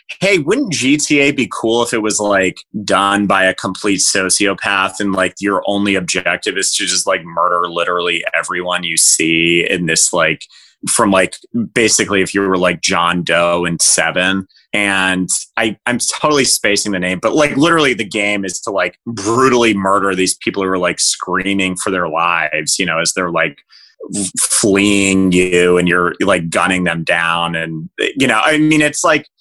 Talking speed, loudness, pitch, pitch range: 180 wpm, -13 LUFS, 95 Hz, 90-105 Hz